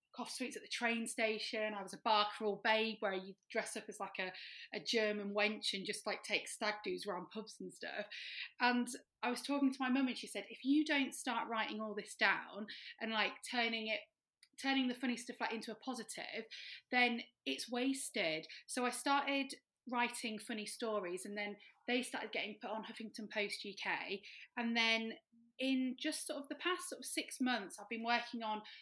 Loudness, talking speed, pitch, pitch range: -39 LUFS, 200 wpm, 225 Hz, 210-250 Hz